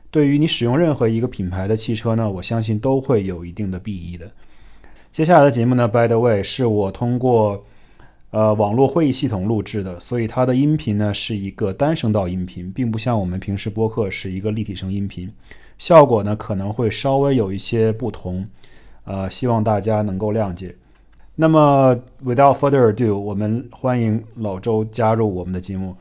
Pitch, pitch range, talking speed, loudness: 110 Hz, 100-120 Hz, 330 characters per minute, -19 LUFS